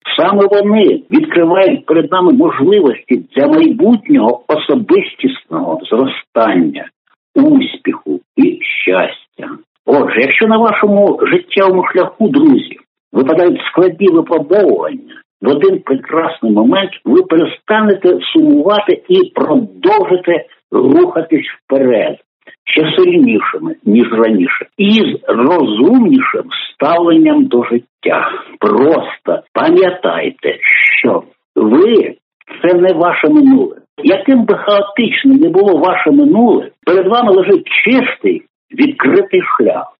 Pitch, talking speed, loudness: 275 Hz, 100 wpm, -11 LUFS